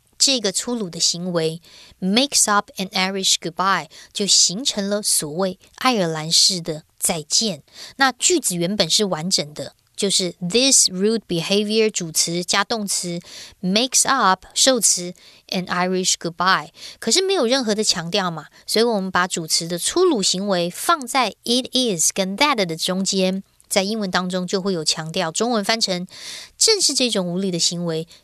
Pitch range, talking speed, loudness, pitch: 175-220 Hz, 330 characters per minute, -19 LUFS, 195 Hz